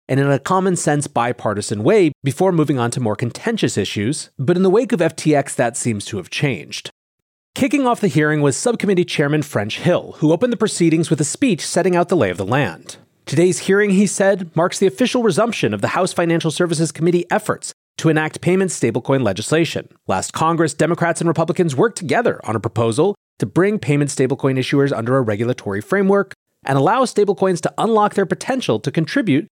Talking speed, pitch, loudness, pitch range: 195 wpm, 165 Hz, -18 LUFS, 135-190 Hz